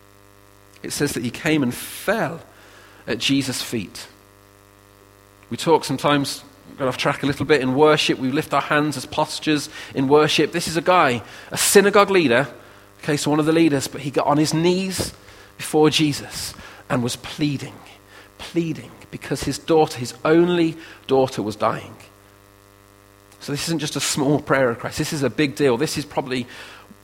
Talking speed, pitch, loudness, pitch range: 175 wpm, 135 Hz, -20 LUFS, 100-155 Hz